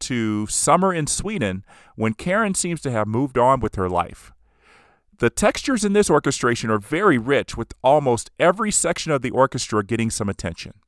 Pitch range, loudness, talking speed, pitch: 105-155 Hz, -20 LUFS, 175 wpm, 120 Hz